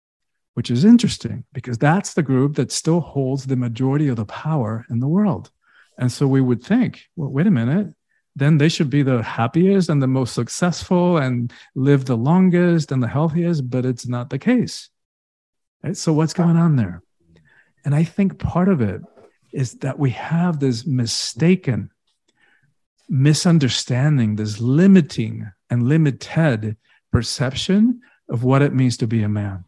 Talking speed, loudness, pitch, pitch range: 165 wpm, -19 LUFS, 135 Hz, 120-165 Hz